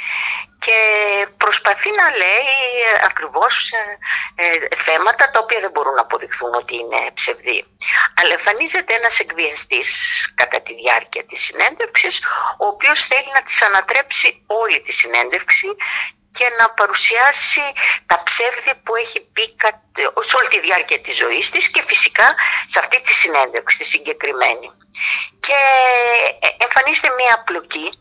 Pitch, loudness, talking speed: 270 Hz, -14 LUFS, 130 wpm